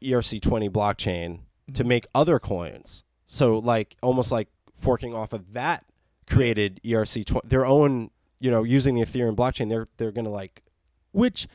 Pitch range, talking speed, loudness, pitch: 110-130 Hz, 160 wpm, -24 LUFS, 115 Hz